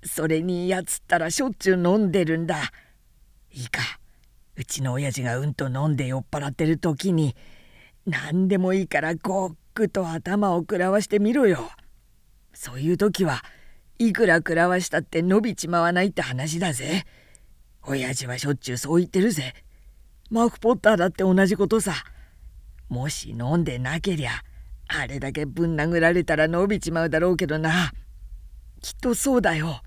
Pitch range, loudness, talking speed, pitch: 135-190 Hz, -23 LUFS, 325 characters per minute, 165 Hz